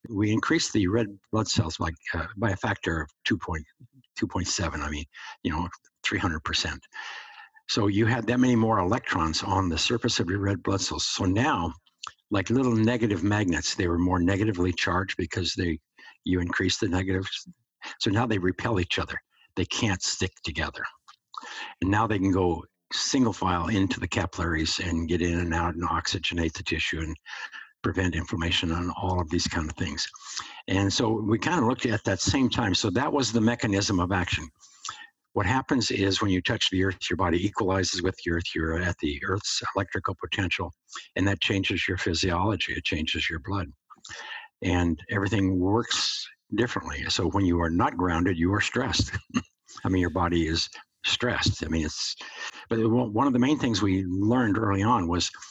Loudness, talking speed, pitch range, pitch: -26 LUFS, 190 wpm, 85-115 Hz, 95 Hz